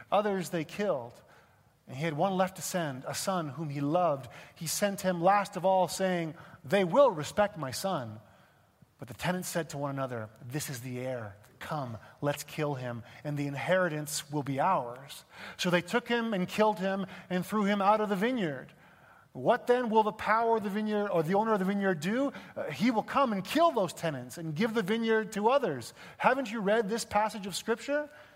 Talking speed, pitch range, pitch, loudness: 205 wpm, 150-210 Hz, 185 Hz, -30 LUFS